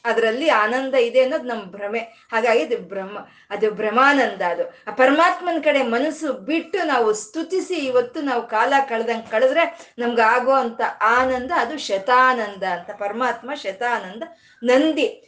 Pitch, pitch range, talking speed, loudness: 250 Hz, 225-300 Hz, 125 wpm, -20 LUFS